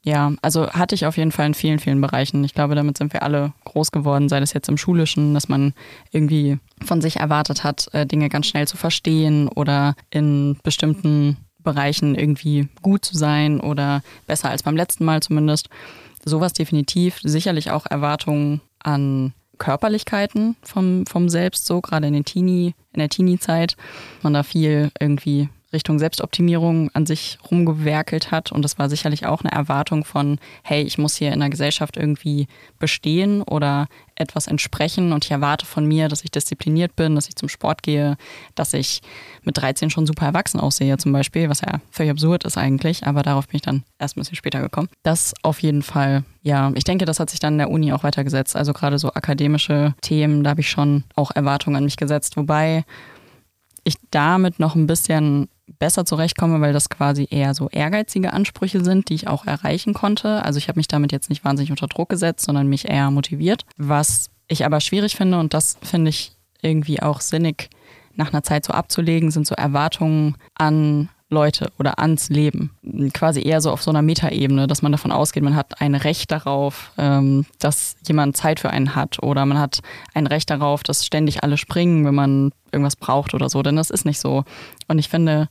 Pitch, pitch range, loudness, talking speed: 150 Hz, 145-160 Hz, -19 LUFS, 195 wpm